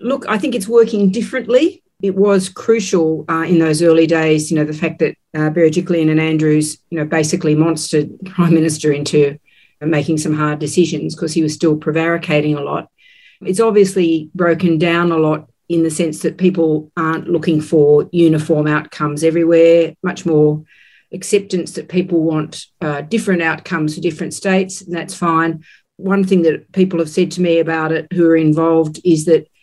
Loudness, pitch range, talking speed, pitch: -15 LUFS, 155-180 Hz, 180 wpm, 165 Hz